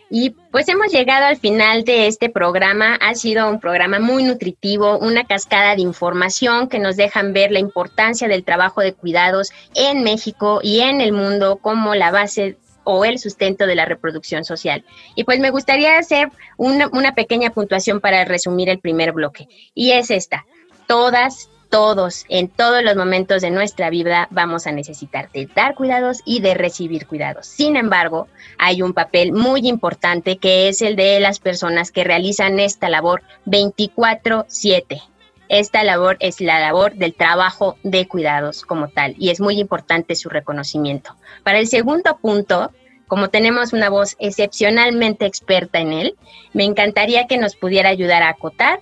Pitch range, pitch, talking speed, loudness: 180-230 Hz, 200 Hz, 165 wpm, -16 LUFS